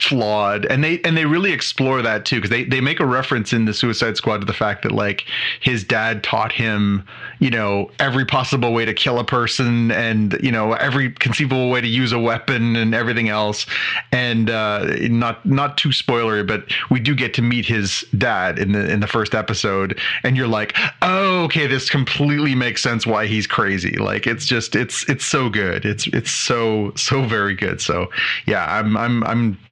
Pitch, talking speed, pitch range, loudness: 120 Hz, 200 wpm, 110-130 Hz, -18 LUFS